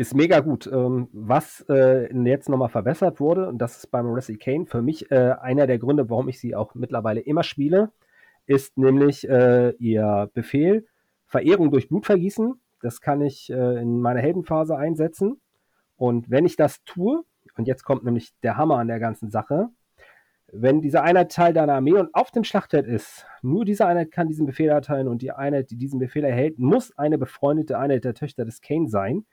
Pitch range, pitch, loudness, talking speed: 125-160 Hz, 140 Hz, -22 LUFS, 190 wpm